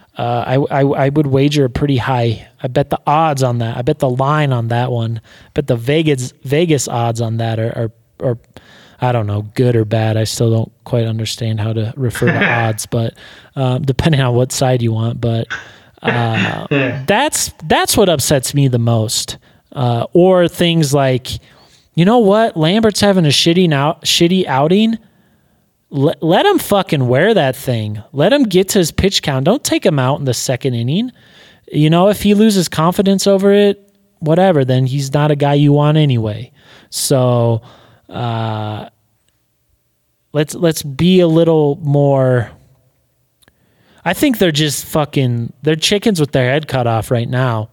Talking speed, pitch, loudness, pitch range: 175 wpm, 135 Hz, -14 LUFS, 120-165 Hz